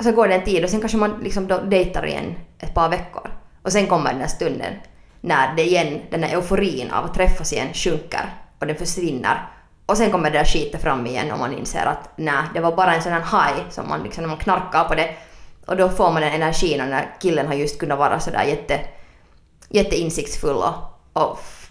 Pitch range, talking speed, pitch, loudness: 155-185 Hz, 225 wpm, 175 Hz, -21 LUFS